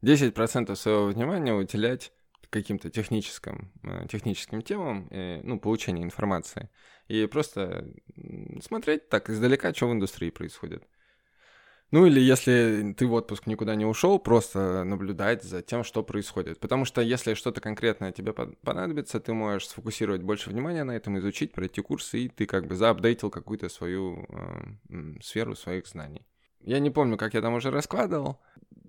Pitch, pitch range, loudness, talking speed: 110 Hz, 100-125 Hz, -28 LUFS, 150 wpm